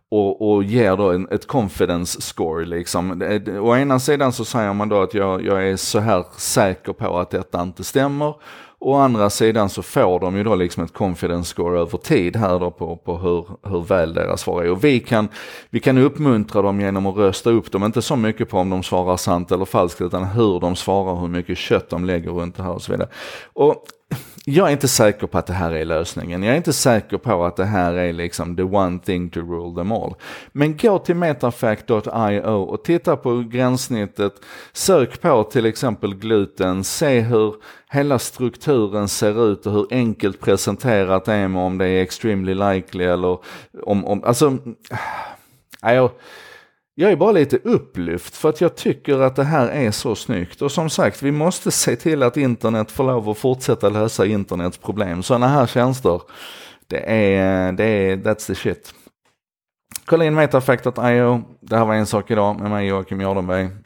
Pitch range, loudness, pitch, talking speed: 95-125 Hz, -19 LUFS, 105 Hz, 190 wpm